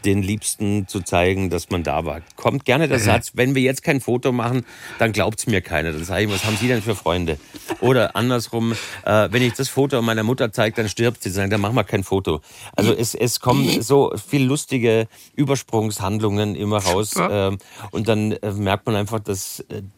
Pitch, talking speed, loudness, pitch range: 110 Hz, 205 wpm, -20 LUFS, 100-120 Hz